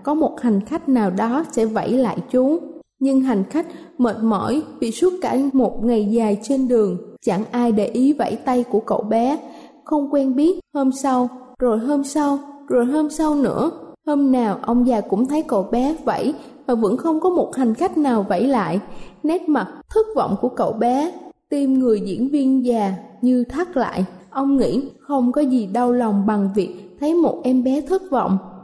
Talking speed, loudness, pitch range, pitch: 195 wpm, -20 LUFS, 225-290 Hz, 255 Hz